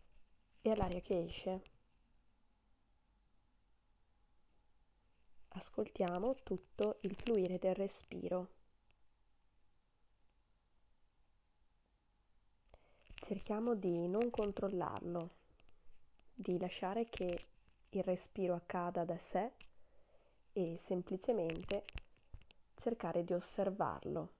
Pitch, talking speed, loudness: 175 Hz, 65 wpm, -41 LUFS